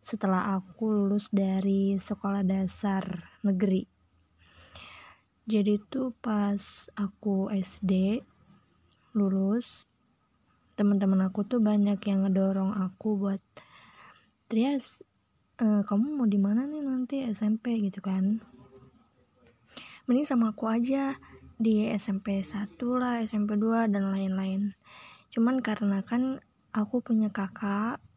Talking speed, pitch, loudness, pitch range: 105 wpm, 205 Hz, -29 LUFS, 195-225 Hz